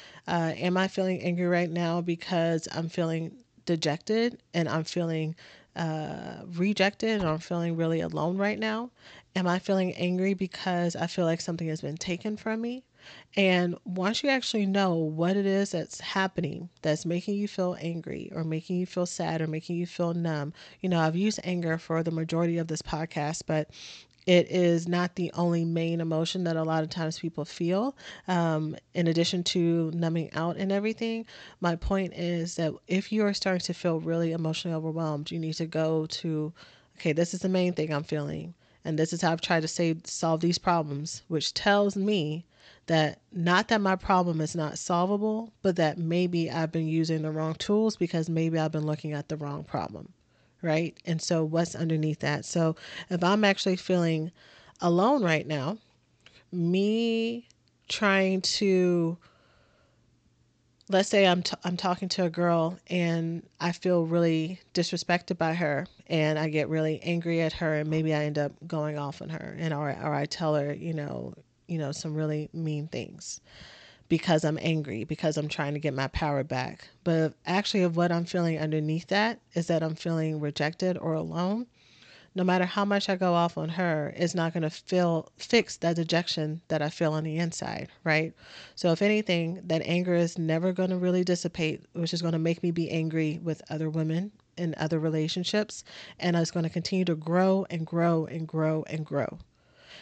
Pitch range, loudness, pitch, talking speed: 160-180 Hz, -28 LUFS, 170 Hz, 190 wpm